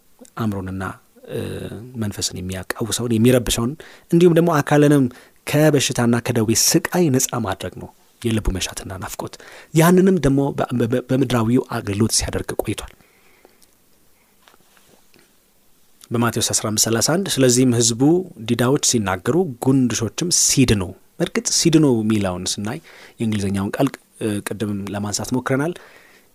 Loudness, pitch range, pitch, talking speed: -19 LUFS, 110-140 Hz, 120 Hz, 90 wpm